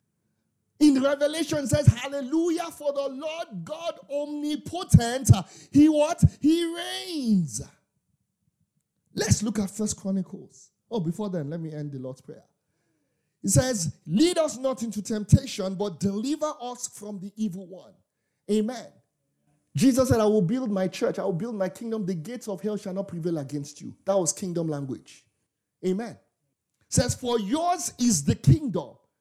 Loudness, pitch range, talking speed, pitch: -26 LUFS, 190-285 Hz, 155 wpm, 215 Hz